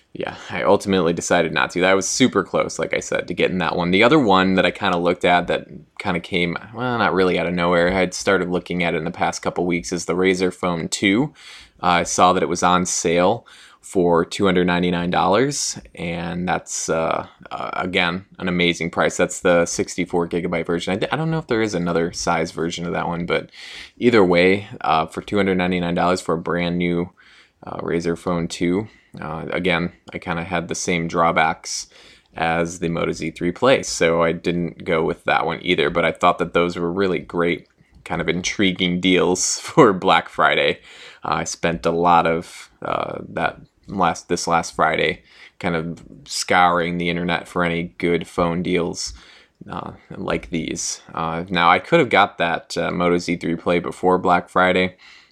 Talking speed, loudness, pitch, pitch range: 195 wpm, -20 LUFS, 85 Hz, 85-90 Hz